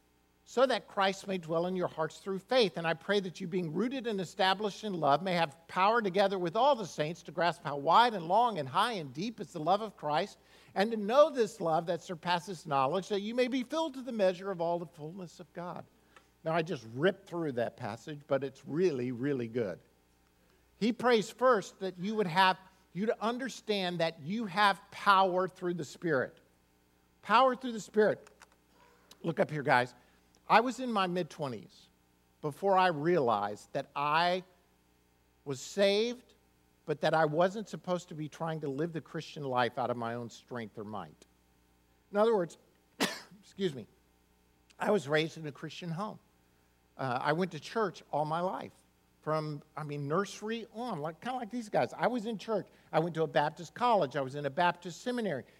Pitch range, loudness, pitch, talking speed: 140-200 Hz, -32 LUFS, 175 Hz, 195 wpm